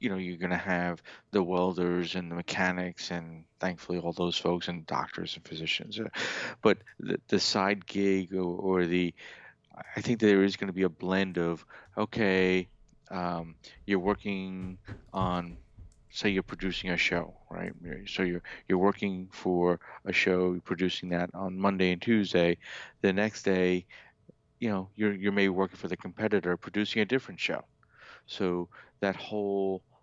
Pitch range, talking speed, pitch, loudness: 90-95 Hz, 165 wpm, 95 Hz, -30 LUFS